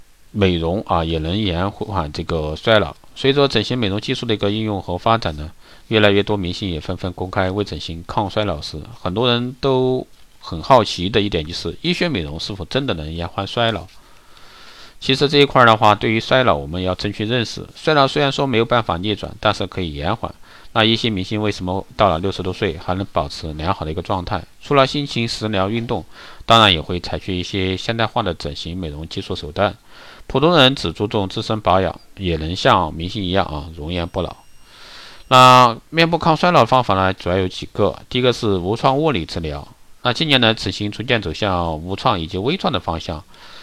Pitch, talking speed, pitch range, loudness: 100 Hz, 310 characters per minute, 85-115 Hz, -18 LUFS